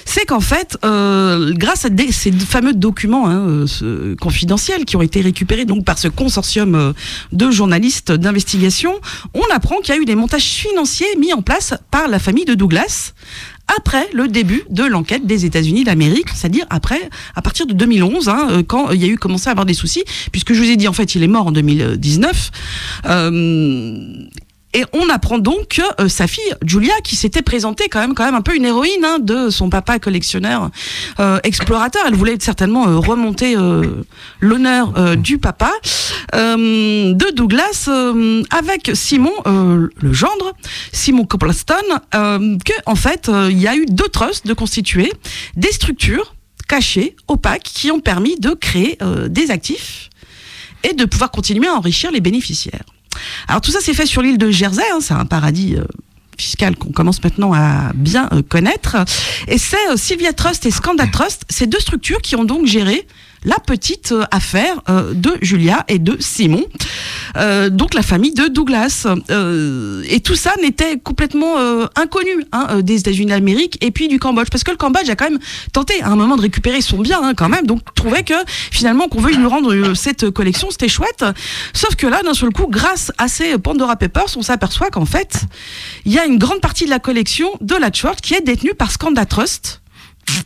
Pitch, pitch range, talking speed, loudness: 225 Hz, 190-280 Hz, 195 wpm, -14 LUFS